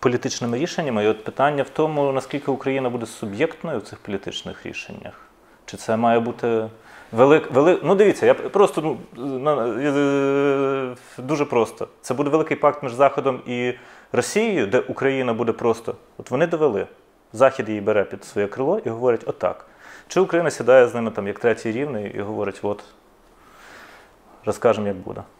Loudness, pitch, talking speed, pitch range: -21 LUFS, 130 Hz, 160 wpm, 115-145 Hz